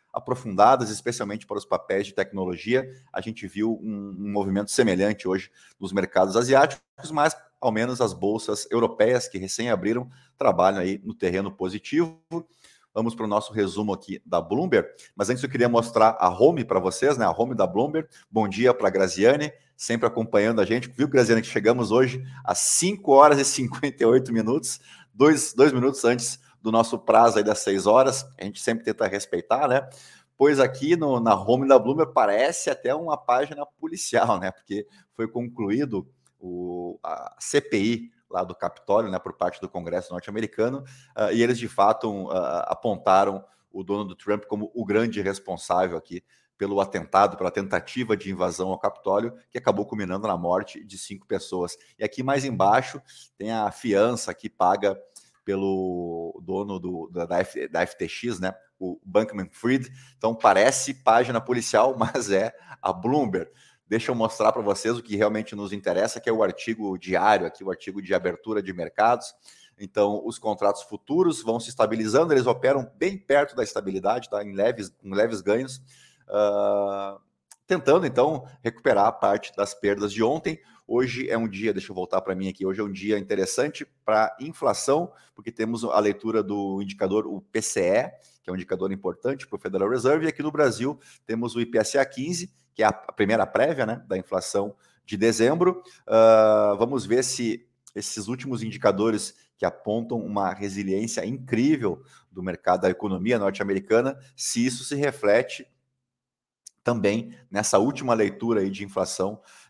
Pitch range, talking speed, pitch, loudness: 100-130 Hz, 170 wpm, 110 Hz, -24 LUFS